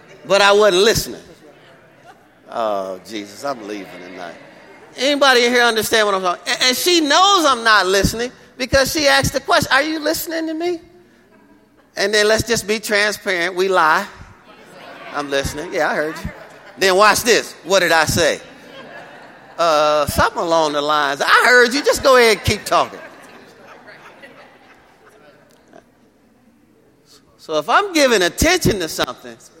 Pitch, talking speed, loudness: 210 Hz, 150 wpm, -15 LUFS